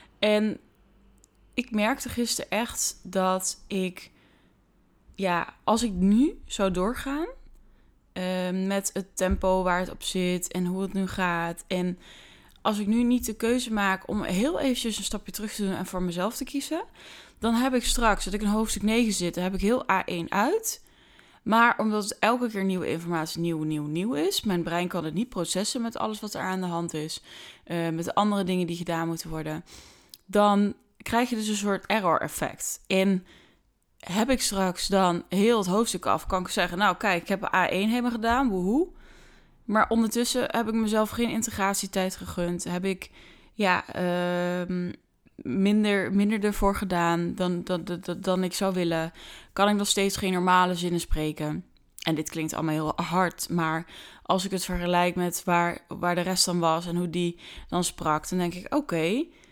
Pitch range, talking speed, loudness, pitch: 175-215 Hz, 185 wpm, -27 LUFS, 190 Hz